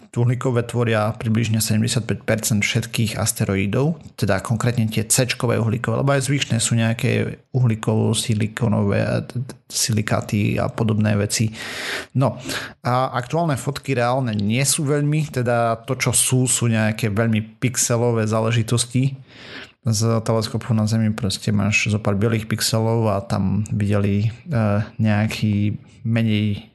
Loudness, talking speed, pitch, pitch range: -20 LUFS, 125 wpm, 115 Hz, 110-125 Hz